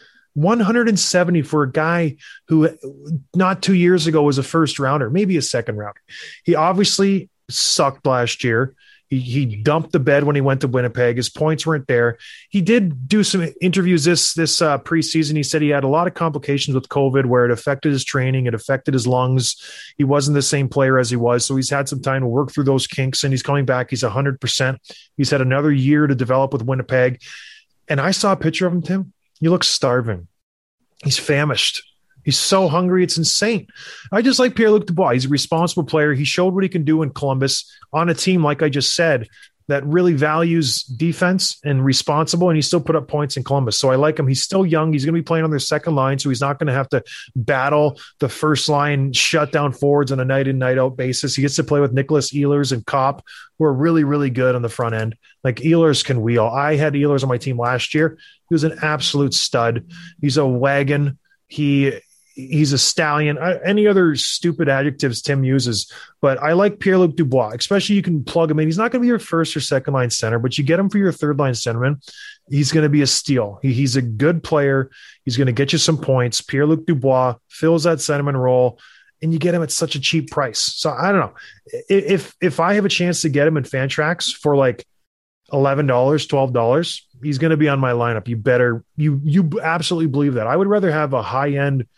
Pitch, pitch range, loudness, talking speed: 145 Hz, 135-165 Hz, -18 LUFS, 225 wpm